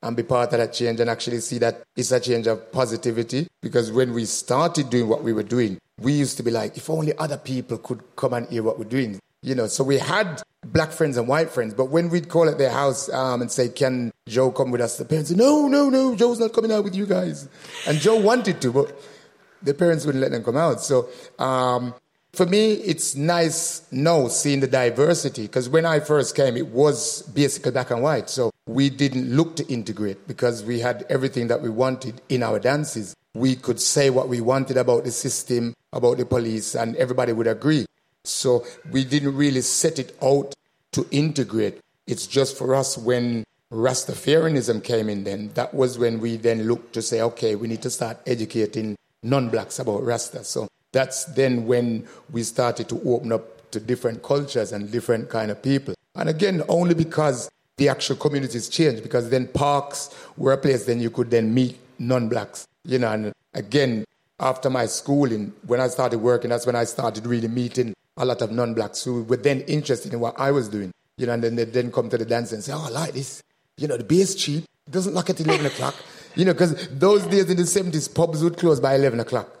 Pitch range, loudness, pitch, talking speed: 120-150 Hz, -22 LUFS, 130 Hz, 215 wpm